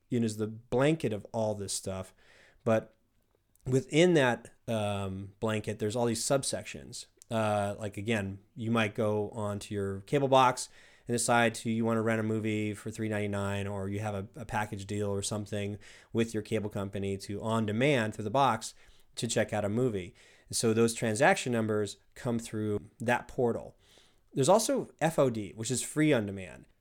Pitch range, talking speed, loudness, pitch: 105-120 Hz, 180 wpm, -31 LUFS, 110 Hz